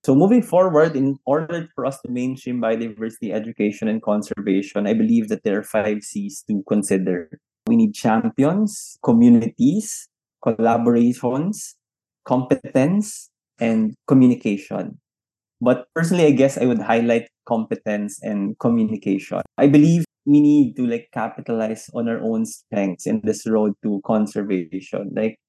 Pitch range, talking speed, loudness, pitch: 110-165 Hz, 135 wpm, -20 LUFS, 120 Hz